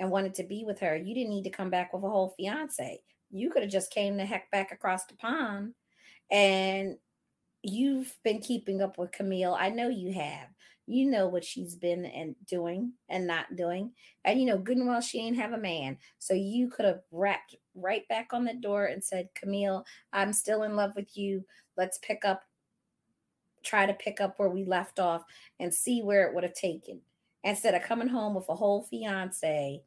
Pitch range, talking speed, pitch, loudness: 185-220 Hz, 210 wpm, 195 Hz, -31 LUFS